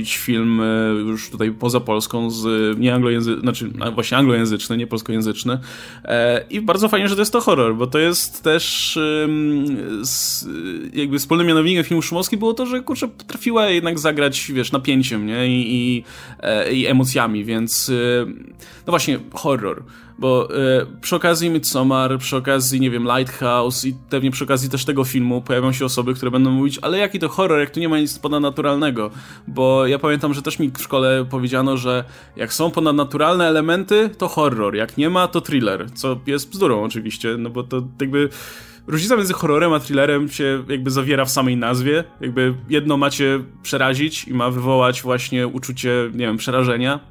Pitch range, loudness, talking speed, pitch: 125-150 Hz, -19 LUFS, 170 wpm, 130 Hz